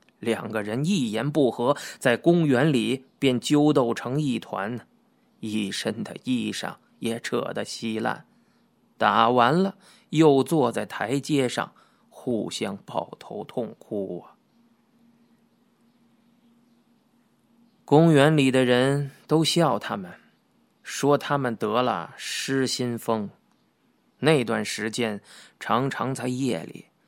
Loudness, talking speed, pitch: -24 LUFS, 155 characters per minute, 145 Hz